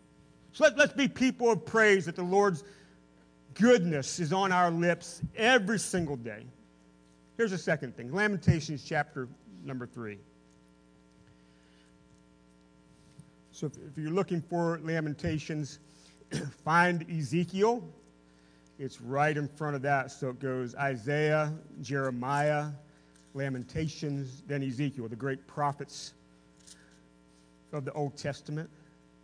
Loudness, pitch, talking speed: -30 LUFS, 140 Hz, 115 wpm